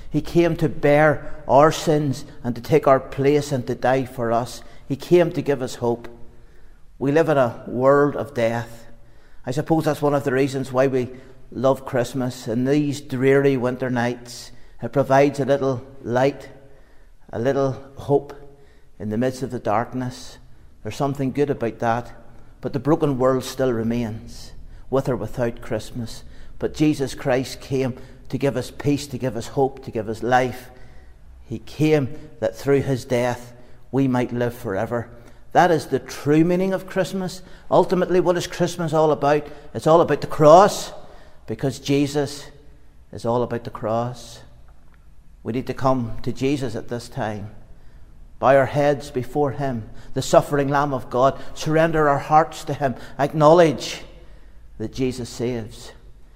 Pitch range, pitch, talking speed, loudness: 120-145 Hz, 130 Hz, 165 wpm, -21 LUFS